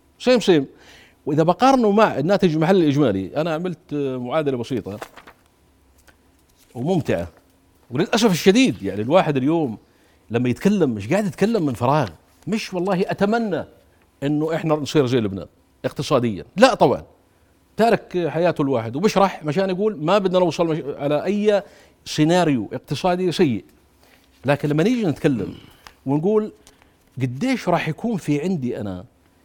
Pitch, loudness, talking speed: 150 Hz, -20 LUFS, 125 wpm